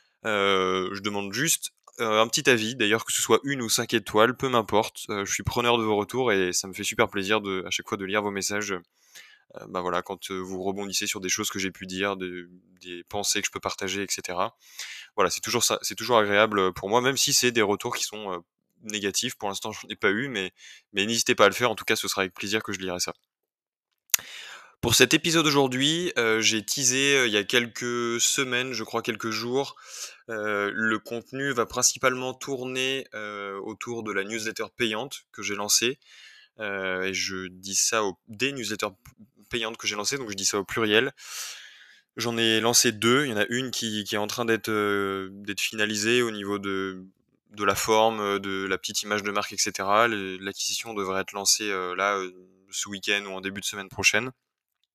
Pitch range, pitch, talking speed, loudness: 100-120 Hz, 105 Hz, 215 wpm, -25 LUFS